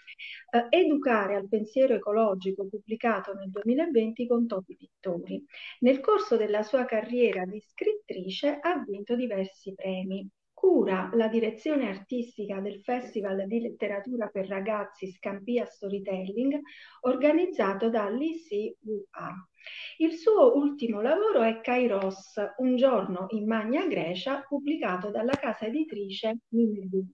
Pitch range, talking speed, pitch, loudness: 200-265 Hz, 115 wpm, 225 Hz, -28 LUFS